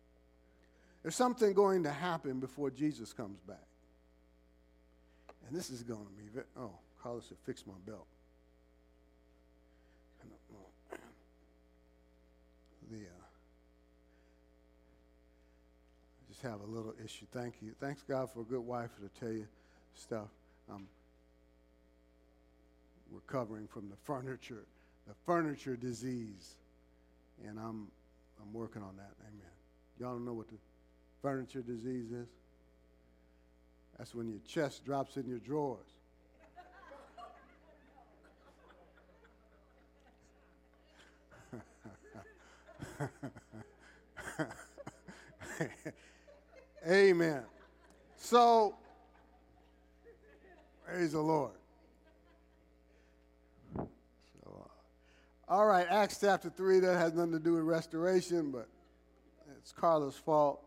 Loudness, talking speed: -36 LUFS, 95 wpm